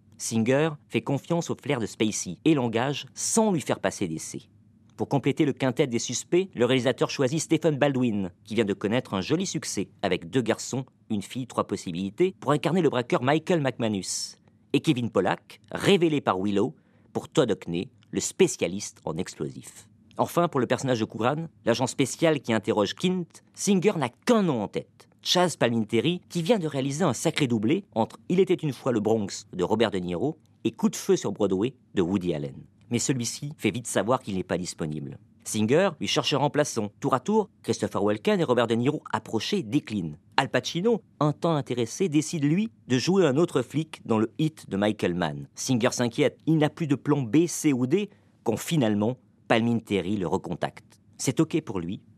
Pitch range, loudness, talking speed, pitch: 110-155 Hz, -26 LUFS, 190 wpm, 130 Hz